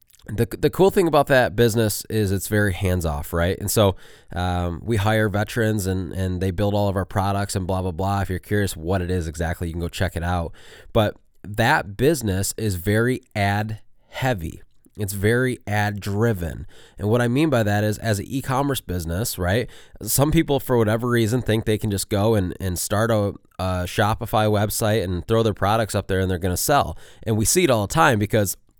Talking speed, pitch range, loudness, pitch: 215 wpm, 95-115 Hz, -22 LUFS, 105 Hz